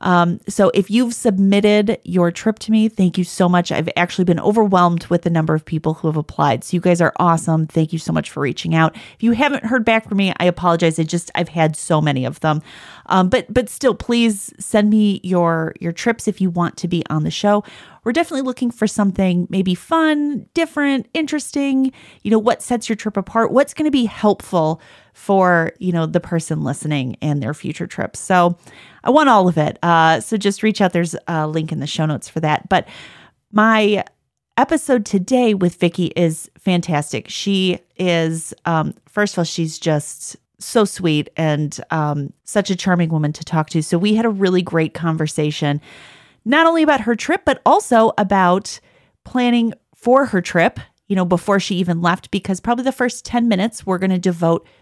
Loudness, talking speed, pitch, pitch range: -17 LUFS, 200 wpm, 185 Hz, 165-220 Hz